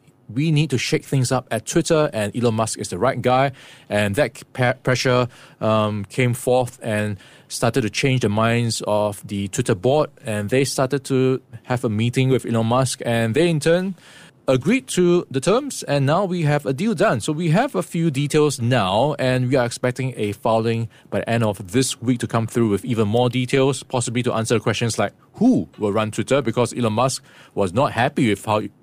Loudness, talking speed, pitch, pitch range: -20 LUFS, 210 wpm, 125 Hz, 115-140 Hz